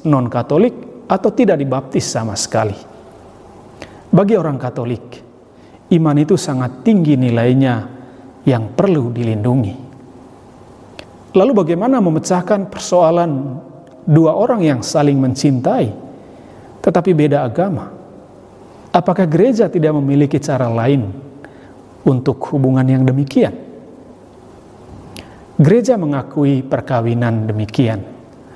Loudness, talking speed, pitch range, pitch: -15 LUFS, 90 wpm, 125-165 Hz, 135 Hz